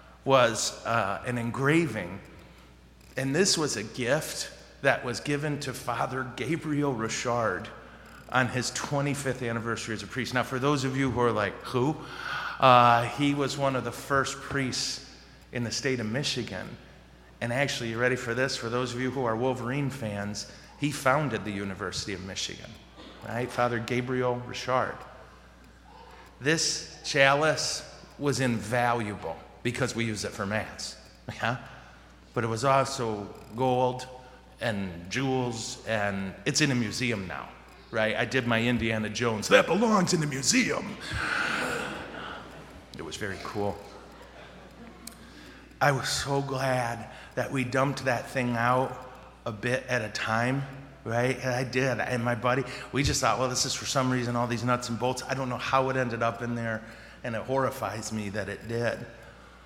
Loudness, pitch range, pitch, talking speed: -28 LUFS, 110-135 Hz, 125 Hz, 160 wpm